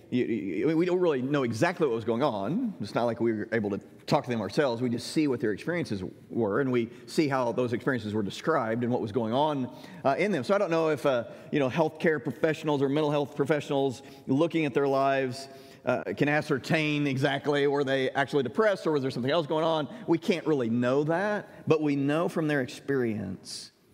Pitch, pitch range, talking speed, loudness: 145 Hz, 125-155 Hz, 225 wpm, -28 LUFS